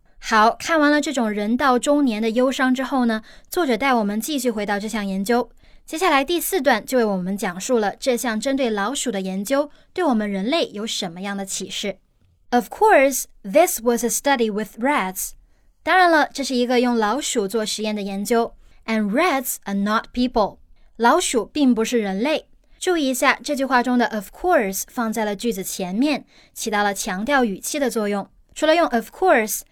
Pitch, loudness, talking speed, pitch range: 235 Hz, -20 LUFS, 360 characters per minute, 210-275 Hz